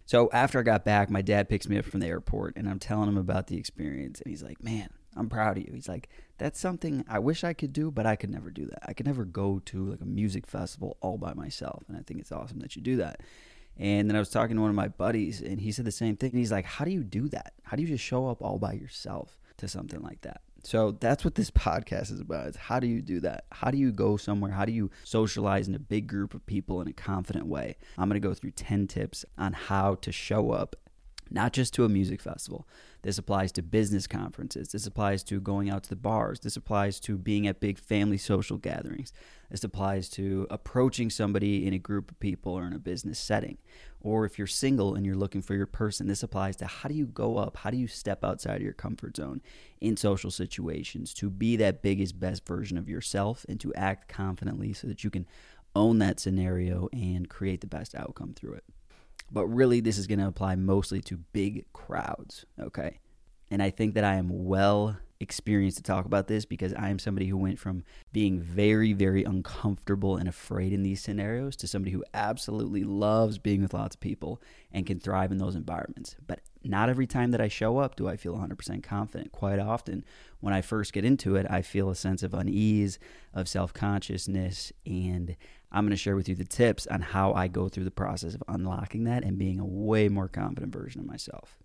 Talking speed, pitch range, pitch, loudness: 235 wpm, 95-110 Hz, 100 Hz, -30 LUFS